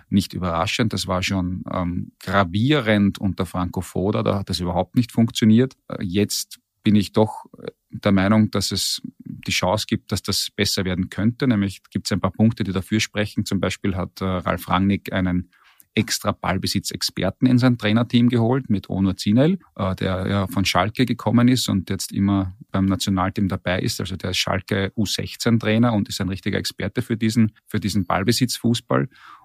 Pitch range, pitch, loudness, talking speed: 95-110 Hz, 100 Hz, -21 LUFS, 175 wpm